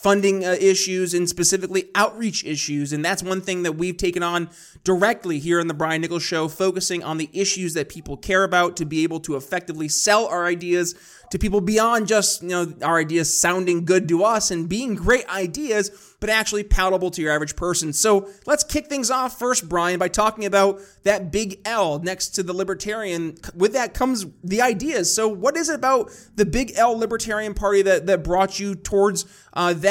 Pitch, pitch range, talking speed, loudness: 190 Hz, 175-210 Hz, 200 wpm, -21 LUFS